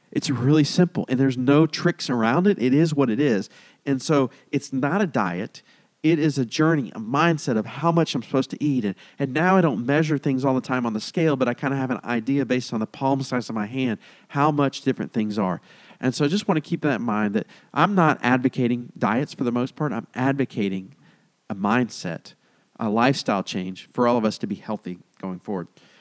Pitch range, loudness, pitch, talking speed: 120-155 Hz, -23 LUFS, 135 Hz, 235 wpm